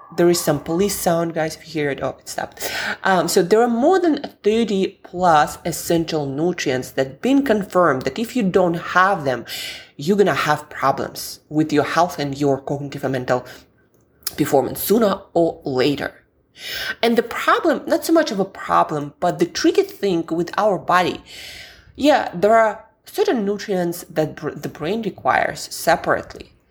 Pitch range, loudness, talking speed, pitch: 150-215 Hz, -19 LUFS, 175 wpm, 175 Hz